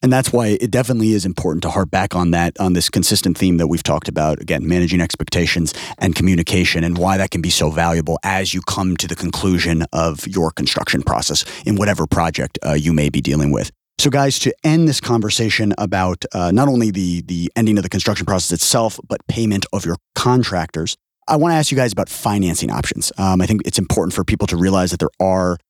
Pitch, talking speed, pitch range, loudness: 95 Hz, 220 wpm, 85-110 Hz, -17 LUFS